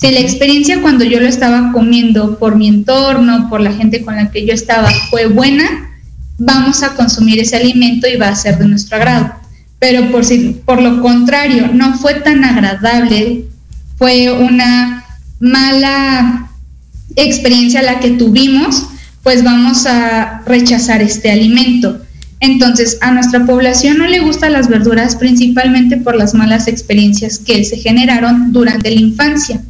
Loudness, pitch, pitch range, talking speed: -9 LUFS, 245 Hz, 225-255 Hz, 155 wpm